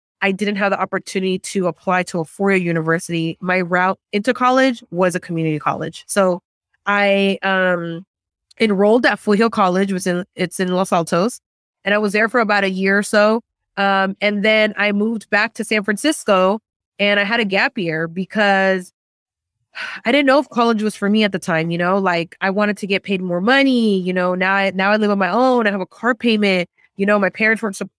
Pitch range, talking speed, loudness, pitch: 185-215 Hz, 220 wpm, -17 LUFS, 195 Hz